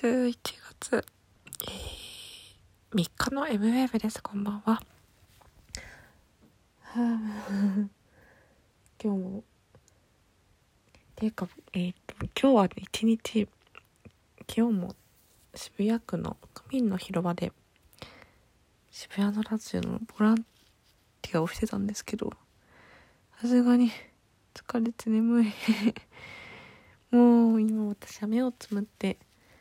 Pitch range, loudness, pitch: 195-230 Hz, -29 LUFS, 215 Hz